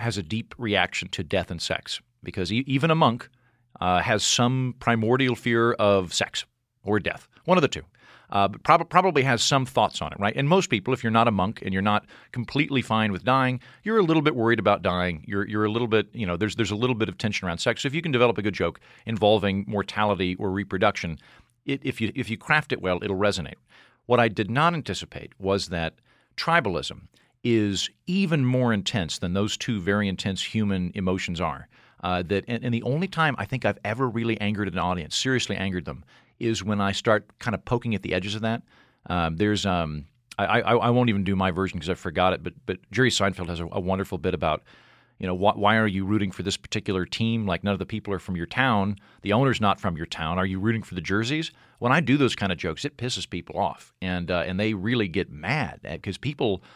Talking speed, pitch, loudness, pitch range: 235 wpm, 105 Hz, -25 LUFS, 95-120 Hz